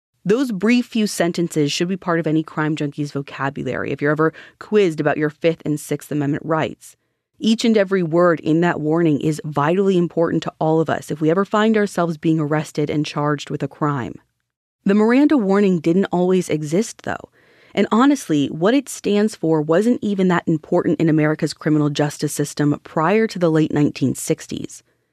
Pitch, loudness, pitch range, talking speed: 160 Hz, -19 LUFS, 150-195 Hz, 180 wpm